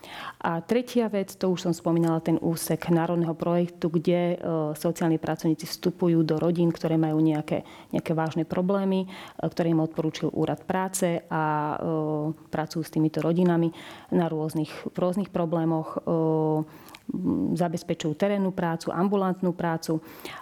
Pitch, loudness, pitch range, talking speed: 165 Hz, -26 LUFS, 160-175 Hz, 130 wpm